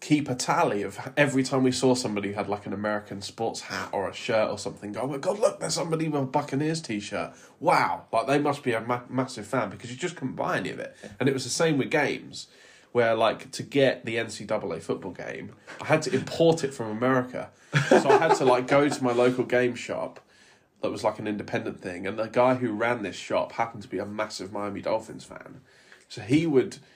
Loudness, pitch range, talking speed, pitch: -26 LUFS, 110-135 Hz, 230 wpm, 125 Hz